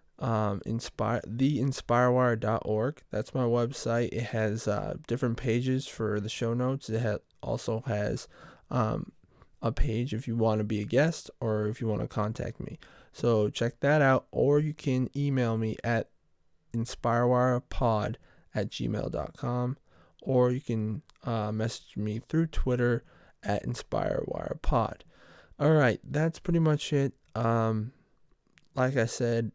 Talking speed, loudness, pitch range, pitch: 140 wpm, -30 LUFS, 110-130 Hz, 120 Hz